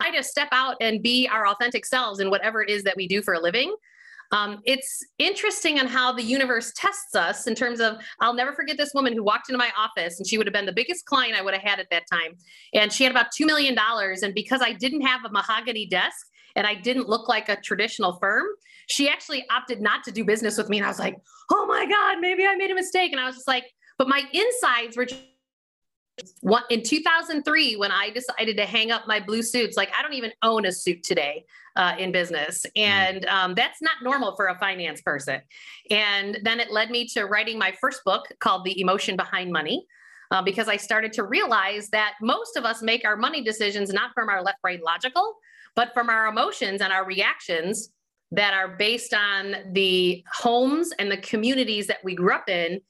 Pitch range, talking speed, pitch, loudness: 200-265 Hz, 225 wpm, 225 Hz, -23 LUFS